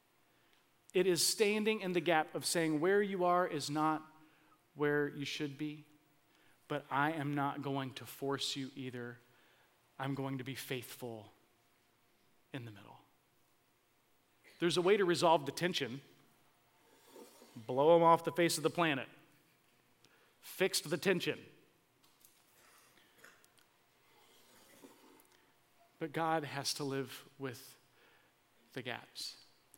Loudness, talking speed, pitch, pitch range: -35 LUFS, 120 wpm, 145 Hz, 135-165 Hz